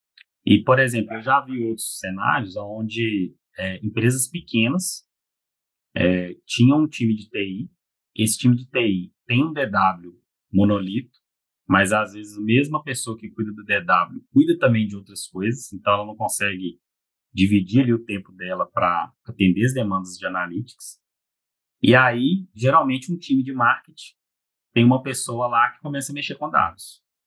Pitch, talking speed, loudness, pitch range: 115 Hz, 160 wpm, -21 LUFS, 100-130 Hz